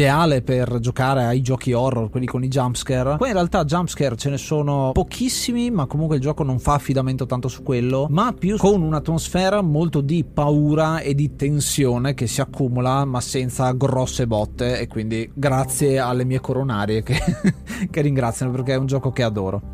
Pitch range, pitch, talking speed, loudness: 125-155 Hz, 135 Hz, 180 wpm, -20 LUFS